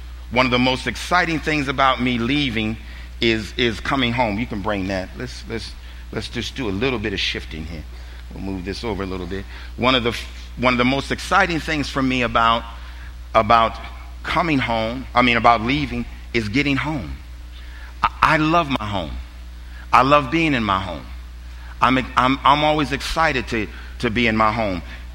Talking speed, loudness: 190 wpm, -20 LUFS